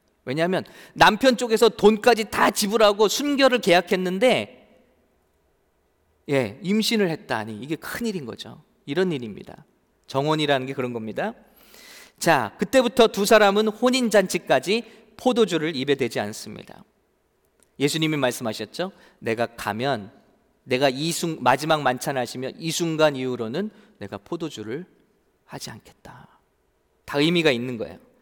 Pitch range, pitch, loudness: 130-215 Hz, 165 Hz, -22 LUFS